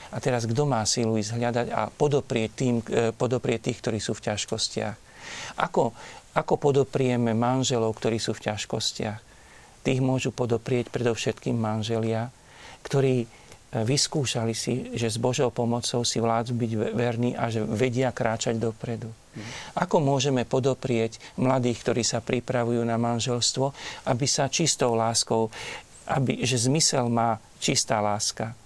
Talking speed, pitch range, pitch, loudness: 130 wpm, 115-130 Hz, 120 Hz, -26 LUFS